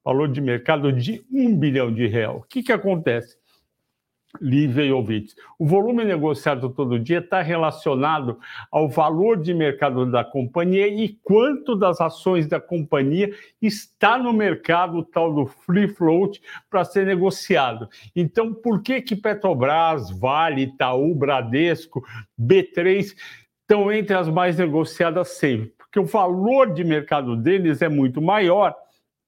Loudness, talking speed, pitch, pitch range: -21 LUFS, 140 wpm, 170 Hz, 140-195 Hz